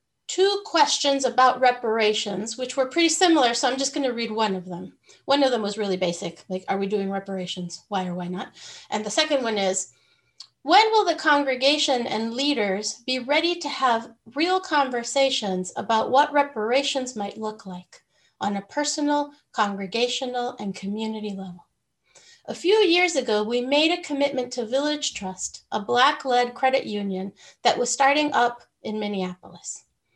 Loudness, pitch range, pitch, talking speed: -23 LUFS, 205-285 Hz, 245 Hz, 165 wpm